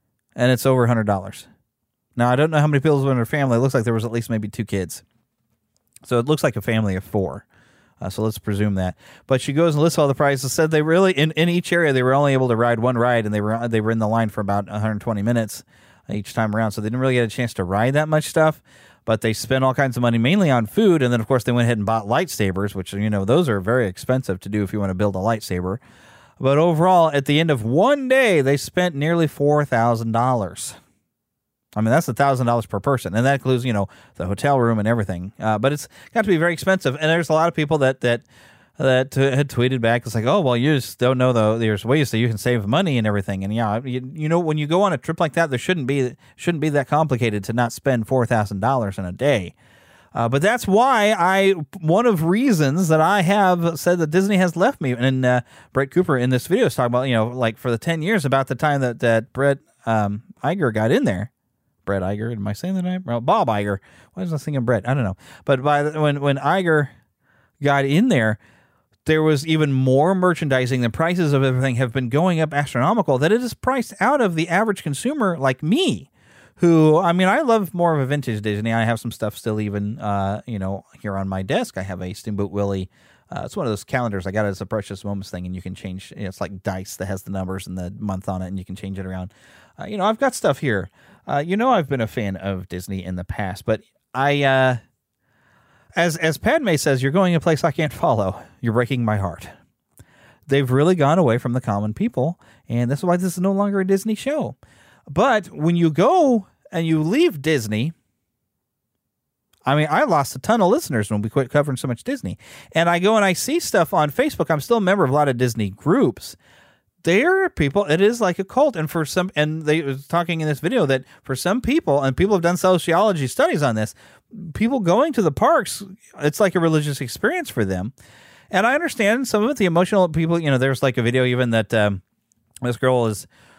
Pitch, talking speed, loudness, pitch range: 130 Hz, 245 wpm, -20 LUFS, 110-160 Hz